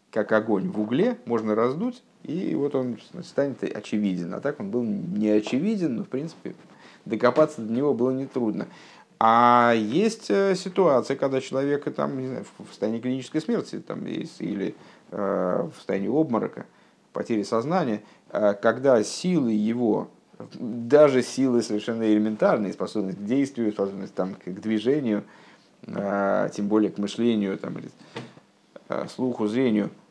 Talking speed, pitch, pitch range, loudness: 130 wpm, 120 Hz, 105-140 Hz, -25 LUFS